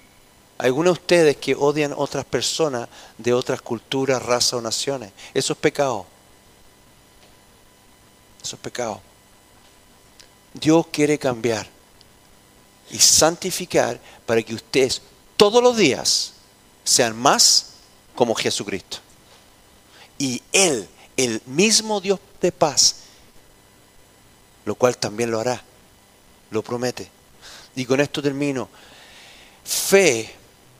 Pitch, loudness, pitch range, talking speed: 125 Hz, -20 LUFS, 105-145 Hz, 105 wpm